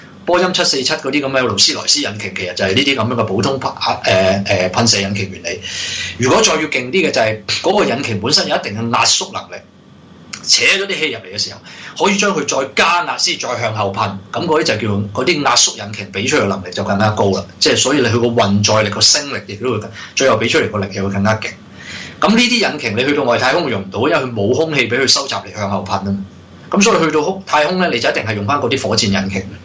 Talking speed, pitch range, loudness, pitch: 360 characters per minute, 100-135 Hz, -14 LUFS, 110 Hz